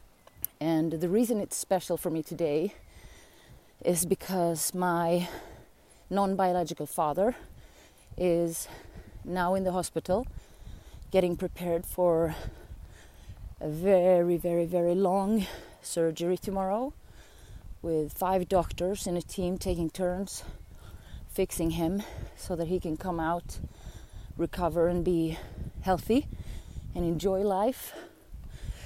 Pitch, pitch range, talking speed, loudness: 175 Hz, 165-185 Hz, 105 wpm, -30 LUFS